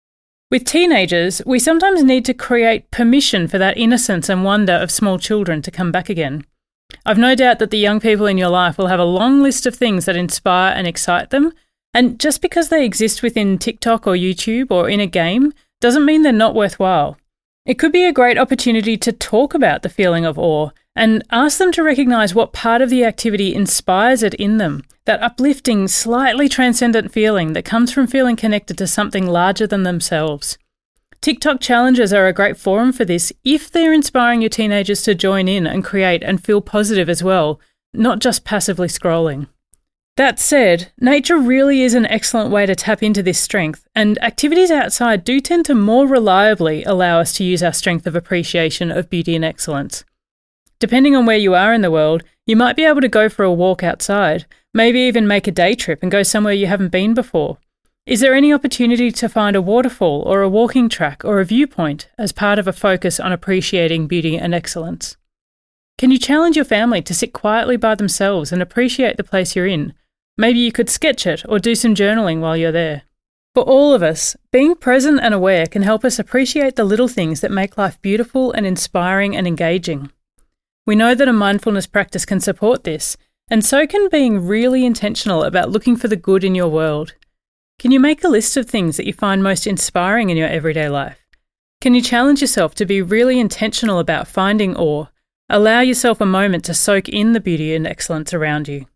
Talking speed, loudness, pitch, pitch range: 200 wpm, -15 LUFS, 210 Hz, 180-245 Hz